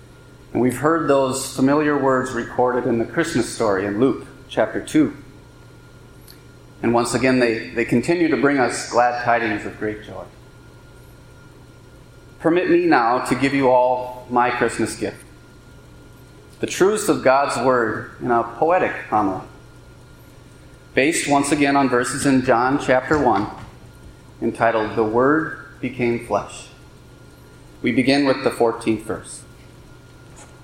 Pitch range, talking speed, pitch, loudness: 120-140 Hz, 135 wpm, 125 Hz, -19 LUFS